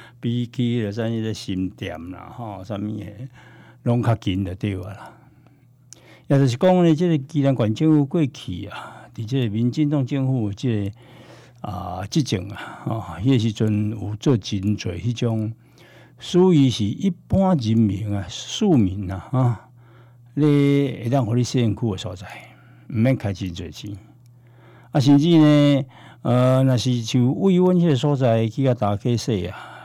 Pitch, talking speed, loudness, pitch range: 120 Hz, 220 characters per minute, -21 LUFS, 105-135 Hz